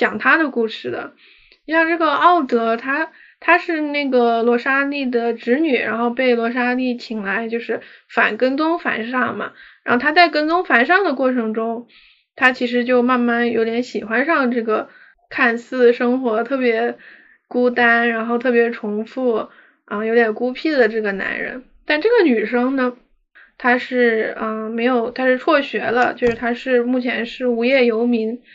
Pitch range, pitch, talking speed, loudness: 235-270 Hz, 245 Hz, 245 characters per minute, -18 LUFS